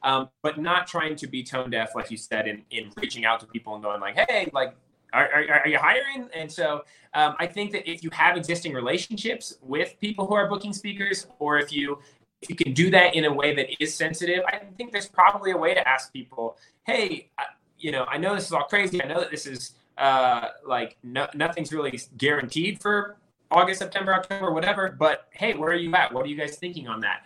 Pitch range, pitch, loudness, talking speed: 135-190 Hz, 160 Hz, -24 LUFS, 235 wpm